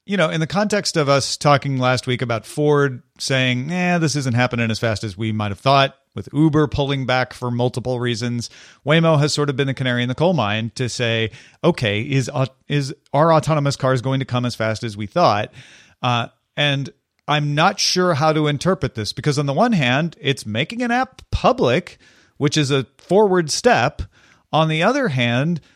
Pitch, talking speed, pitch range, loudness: 140 Hz, 205 wpm, 125-155 Hz, -19 LUFS